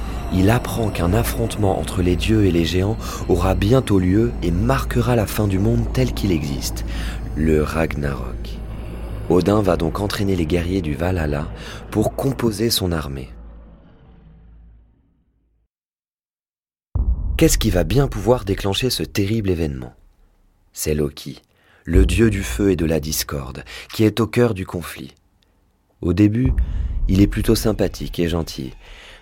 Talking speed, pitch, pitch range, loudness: 140 wpm, 95 Hz, 80-105 Hz, -20 LUFS